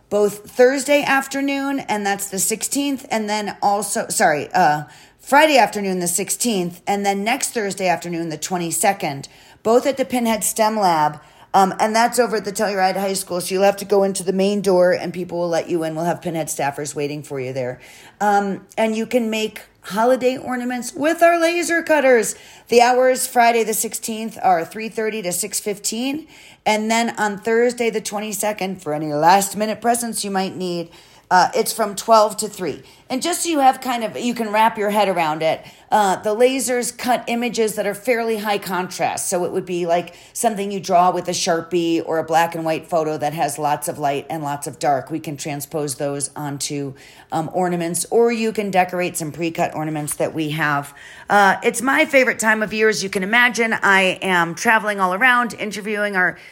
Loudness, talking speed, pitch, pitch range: -19 LUFS, 200 wpm, 200 Hz, 170-230 Hz